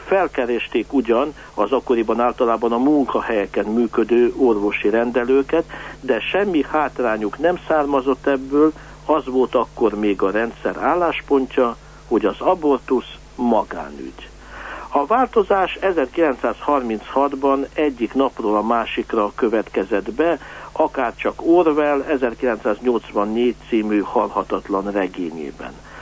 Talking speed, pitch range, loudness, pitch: 95 wpm, 110-140 Hz, -19 LUFS, 130 Hz